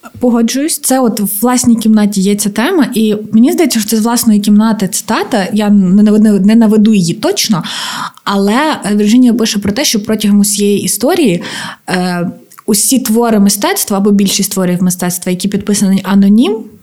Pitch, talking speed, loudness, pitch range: 210 Hz, 145 wpm, -10 LUFS, 200-230 Hz